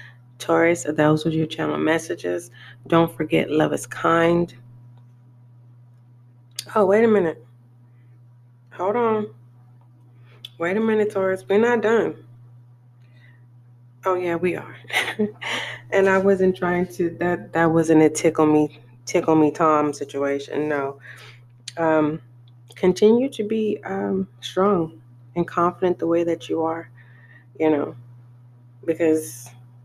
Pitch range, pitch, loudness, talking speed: 120-170 Hz, 150 Hz, -21 LUFS, 120 wpm